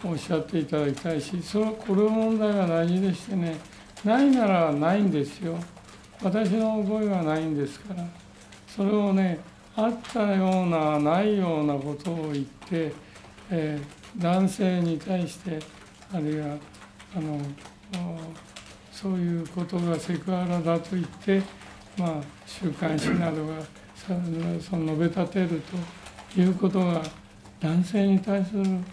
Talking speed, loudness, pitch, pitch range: 265 characters per minute, -27 LUFS, 170 Hz, 155-190 Hz